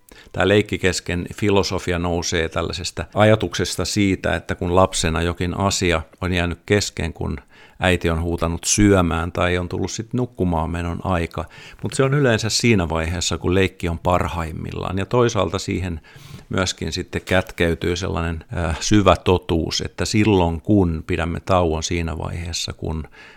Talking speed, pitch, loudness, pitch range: 140 wpm, 90 Hz, -20 LUFS, 85-100 Hz